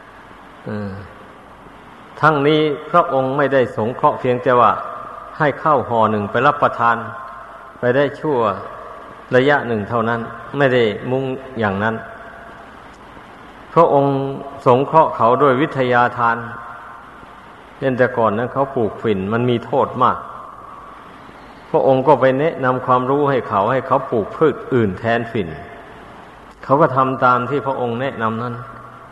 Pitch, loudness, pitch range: 125 Hz, -17 LUFS, 115-135 Hz